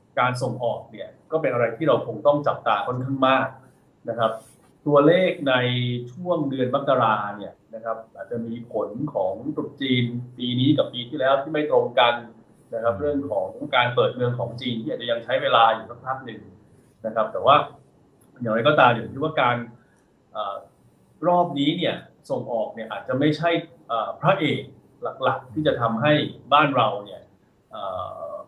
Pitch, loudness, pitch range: 125 Hz, -23 LUFS, 115-145 Hz